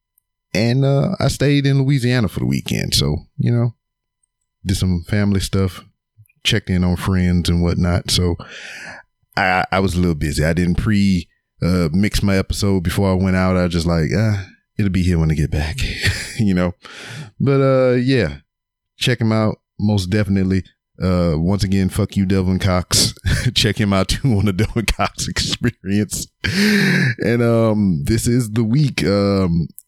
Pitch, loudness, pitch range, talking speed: 100 Hz, -18 LUFS, 90-120 Hz, 170 wpm